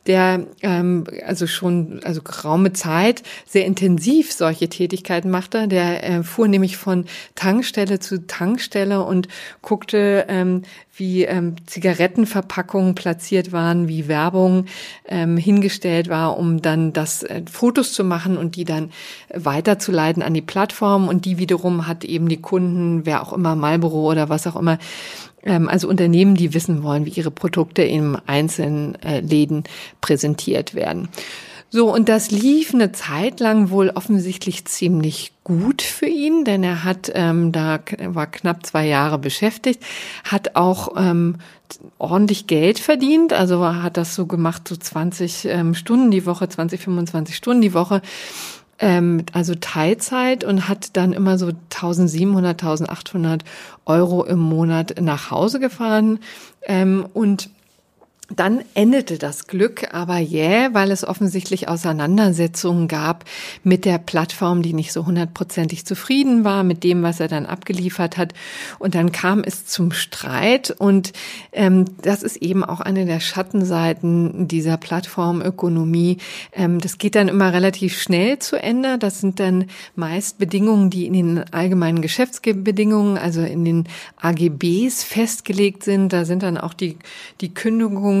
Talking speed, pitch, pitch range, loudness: 145 wpm, 180 Hz, 170-200 Hz, -19 LUFS